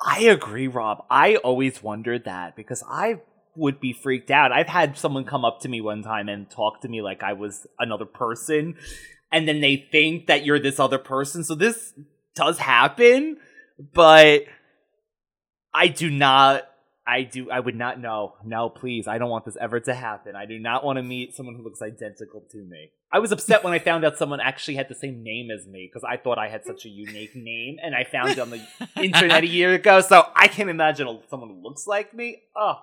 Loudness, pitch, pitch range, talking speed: -20 LUFS, 135 Hz, 115-170 Hz, 220 wpm